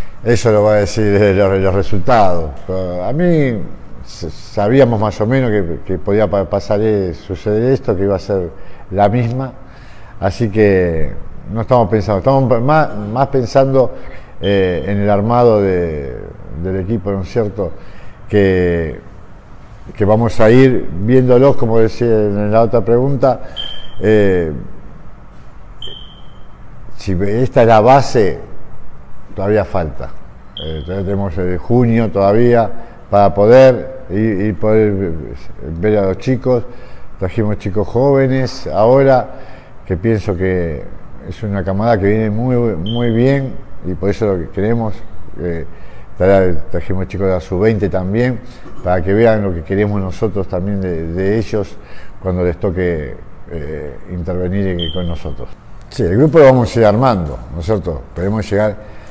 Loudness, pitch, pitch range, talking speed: -14 LUFS, 105 Hz, 95-115 Hz, 140 wpm